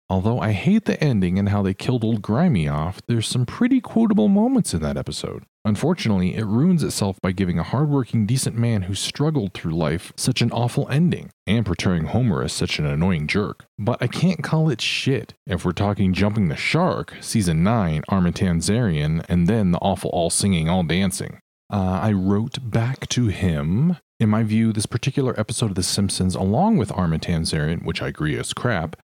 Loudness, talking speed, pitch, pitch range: -21 LUFS, 190 wpm, 110 Hz, 95-135 Hz